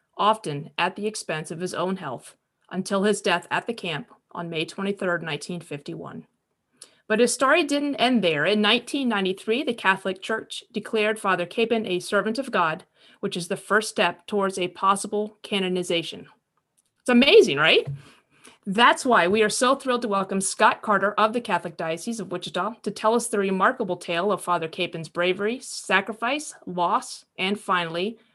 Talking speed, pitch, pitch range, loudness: 165 wpm, 200 Hz, 180-220 Hz, -23 LUFS